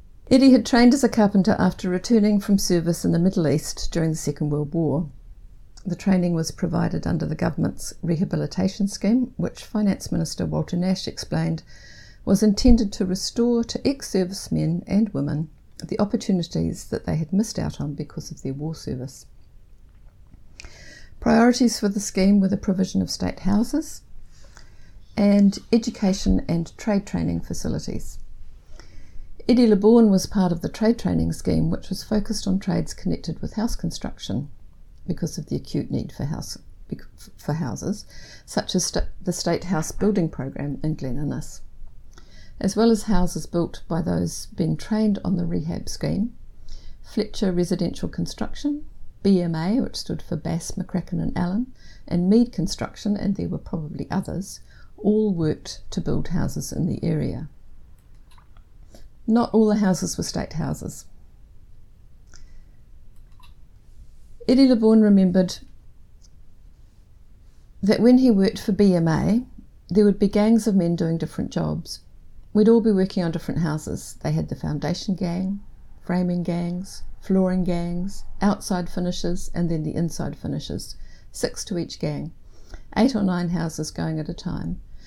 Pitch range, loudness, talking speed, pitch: 150-210 Hz, -23 LUFS, 150 wpm, 180 Hz